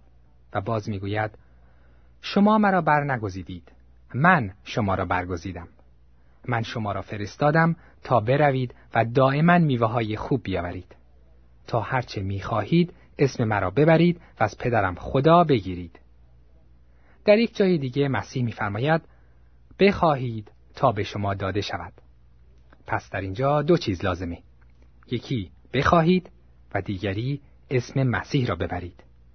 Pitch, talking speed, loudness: 105 Hz, 125 wpm, -24 LUFS